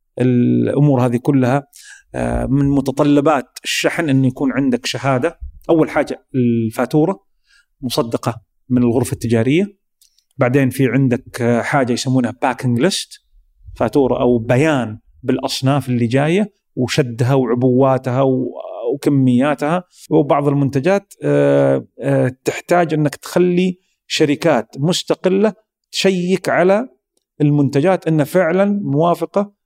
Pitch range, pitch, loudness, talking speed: 125-170 Hz, 140 Hz, -16 LUFS, 95 wpm